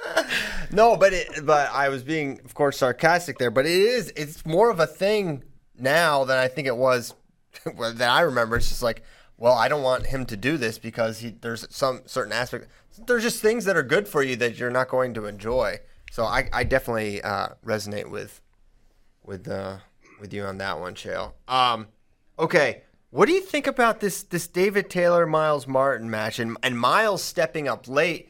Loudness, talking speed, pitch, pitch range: -23 LUFS, 200 wpm, 135 Hz, 115-175 Hz